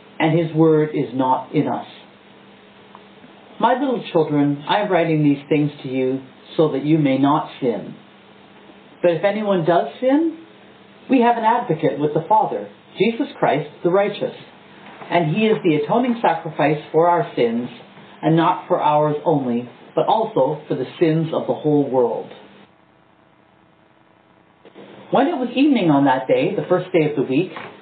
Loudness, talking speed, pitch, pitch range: -19 LUFS, 160 wpm, 165 Hz, 150-210 Hz